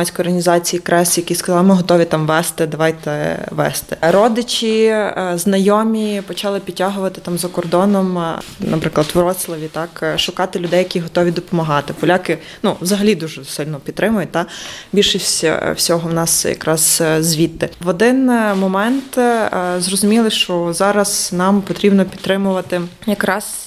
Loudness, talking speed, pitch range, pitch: -16 LUFS, 130 wpm, 170-200 Hz, 180 Hz